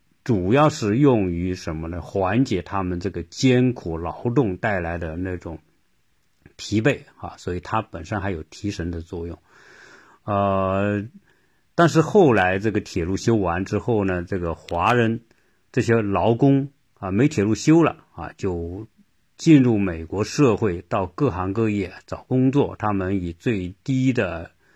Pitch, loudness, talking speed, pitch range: 100 Hz, -22 LUFS, 215 characters per minute, 90-125 Hz